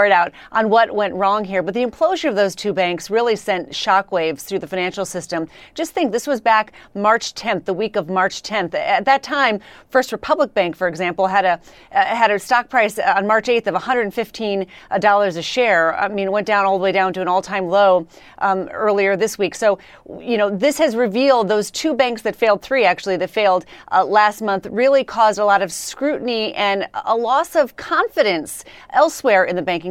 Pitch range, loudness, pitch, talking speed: 190-235 Hz, -18 LUFS, 205 Hz, 210 wpm